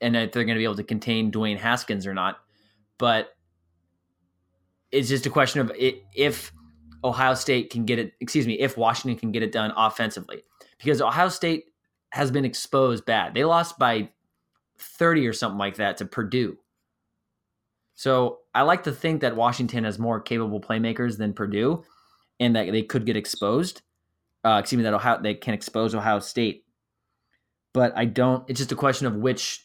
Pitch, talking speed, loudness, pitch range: 115 Hz, 180 wpm, -24 LUFS, 105-130 Hz